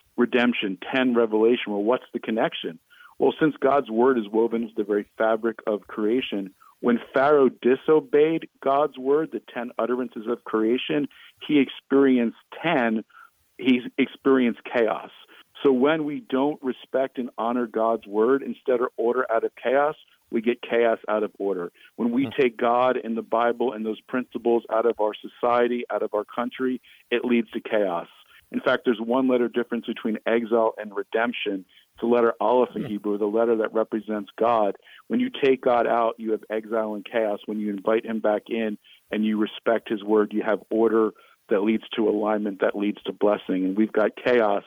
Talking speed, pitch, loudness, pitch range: 180 wpm, 115 Hz, -24 LUFS, 110-125 Hz